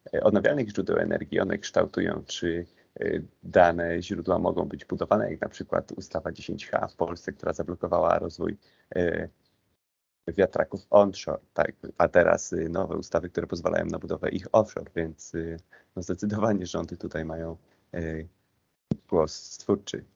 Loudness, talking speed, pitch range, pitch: -28 LUFS, 140 wpm, 80-95 Hz, 85 Hz